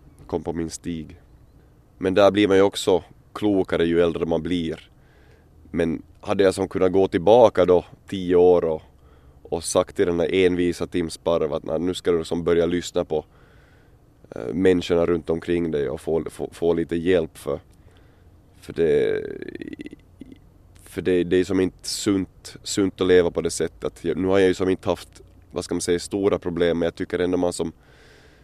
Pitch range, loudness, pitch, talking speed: 85-95 Hz, -22 LUFS, 90 Hz, 190 wpm